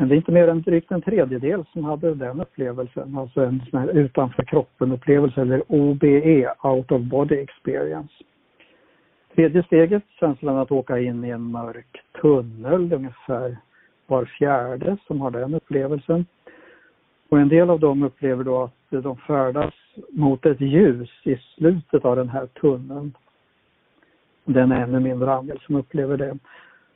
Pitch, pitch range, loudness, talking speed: 140 Hz, 130-155 Hz, -21 LUFS, 155 wpm